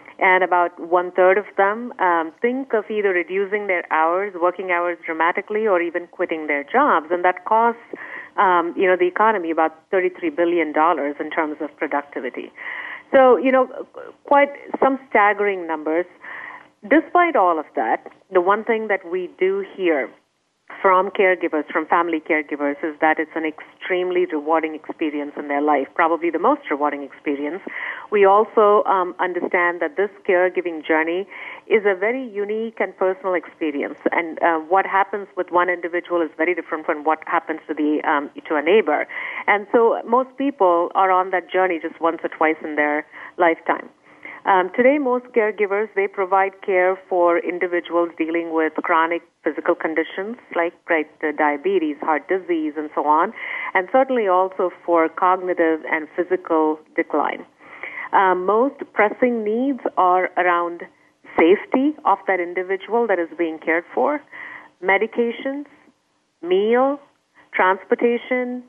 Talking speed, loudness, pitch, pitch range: 150 wpm, -20 LUFS, 185 Hz, 165-220 Hz